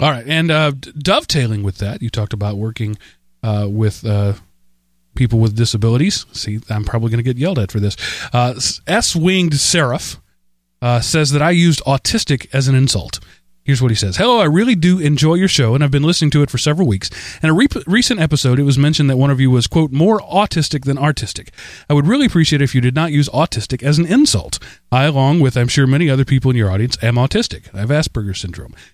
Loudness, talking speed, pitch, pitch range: -15 LUFS, 220 wpm, 130 Hz, 110-155 Hz